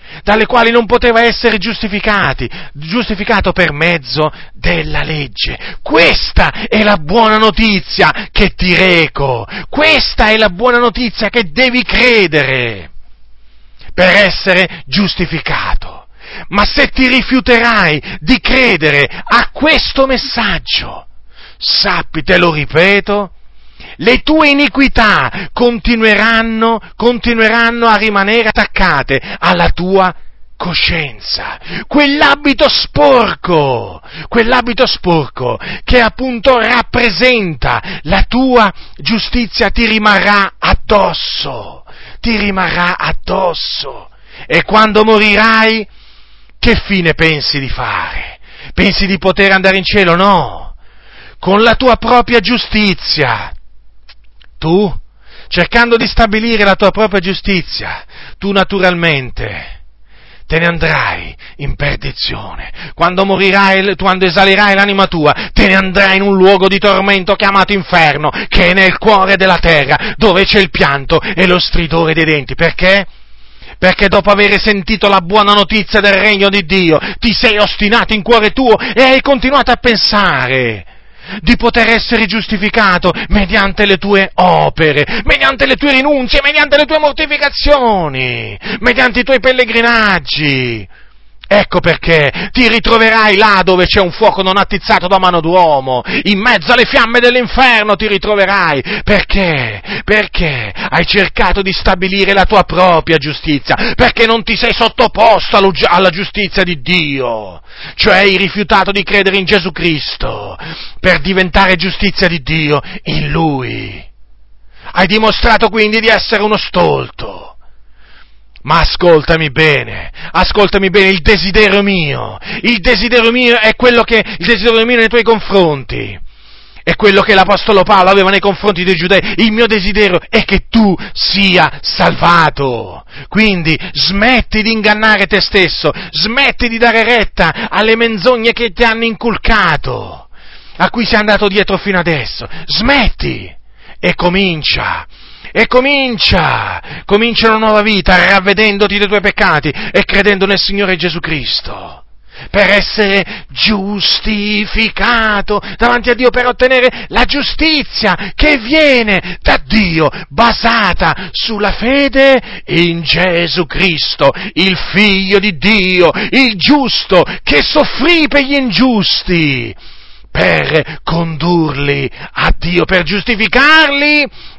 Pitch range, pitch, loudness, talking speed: 175-230 Hz, 200 Hz, -9 LUFS, 125 wpm